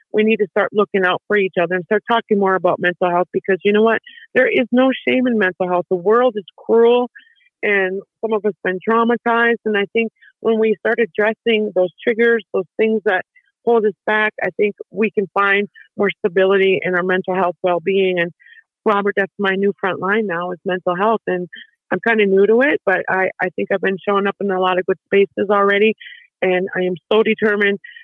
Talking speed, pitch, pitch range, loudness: 220 wpm, 205 Hz, 185-225 Hz, -17 LUFS